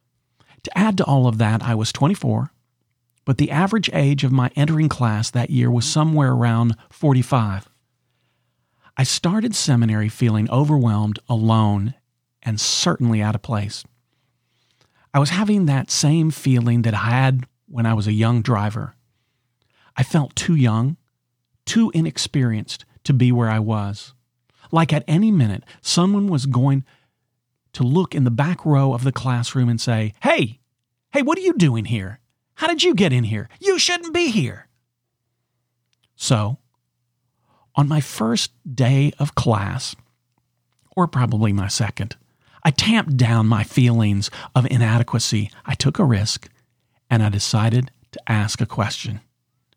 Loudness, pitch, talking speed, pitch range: -19 LUFS, 125 Hz, 150 wpm, 115-140 Hz